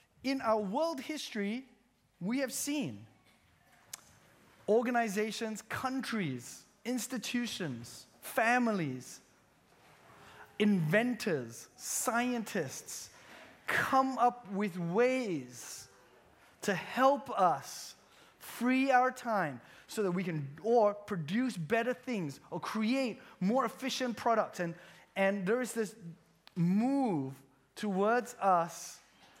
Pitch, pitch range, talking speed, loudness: 215 Hz, 175-245 Hz, 90 wpm, -33 LUFS